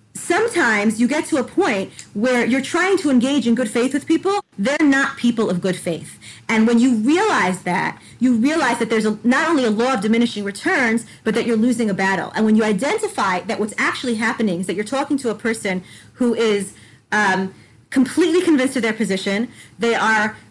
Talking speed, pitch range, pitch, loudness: 205 wpm, 215-275 Hz, 235 Hz, -18 LUFS